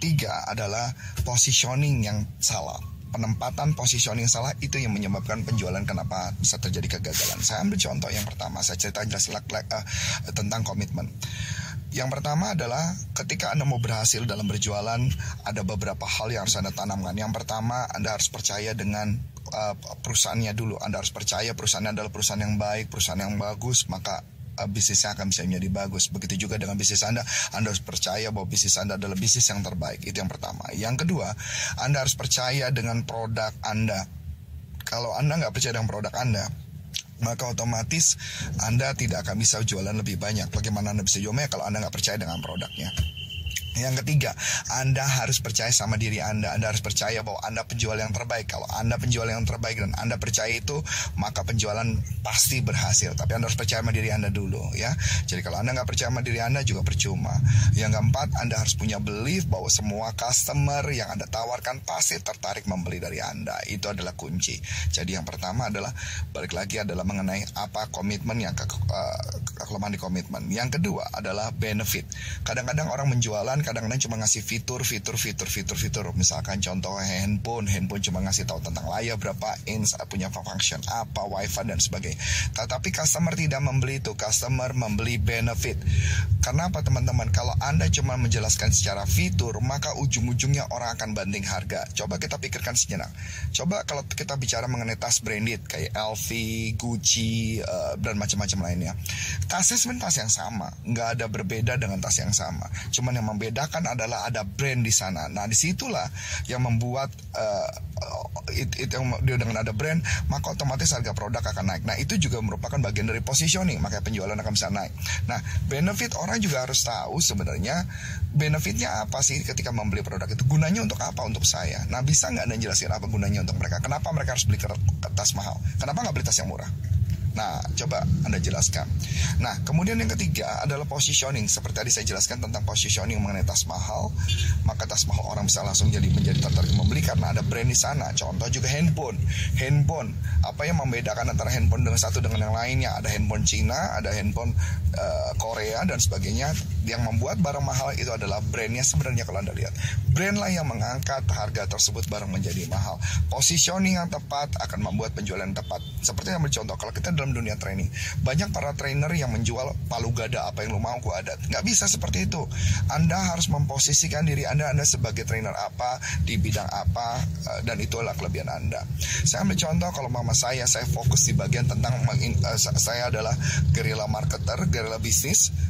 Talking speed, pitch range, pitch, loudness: 175 wpm, 100-120 Hz, 110 Hz, -25 LUFS